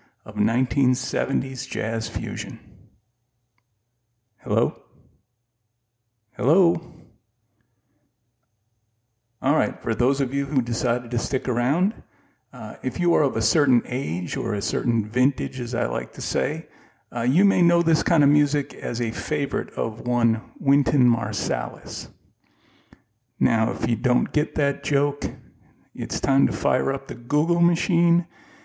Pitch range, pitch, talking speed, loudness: 115-145 Hz, 120 Hz, 135 wpm, -23 LUFS